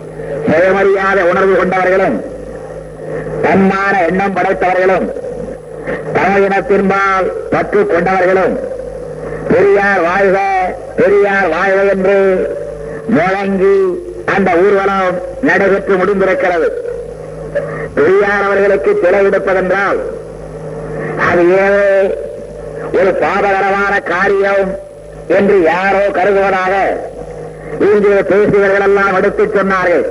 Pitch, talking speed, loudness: 195 Hz, 70 wpm, -12 LUFS